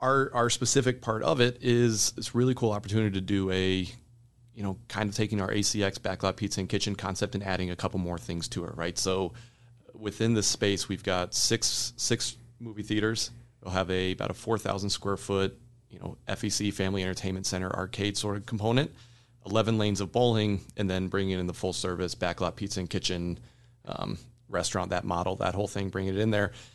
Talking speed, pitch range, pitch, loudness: 195 wpm, 95-120 Hz, 105 Hz, -29 LUFS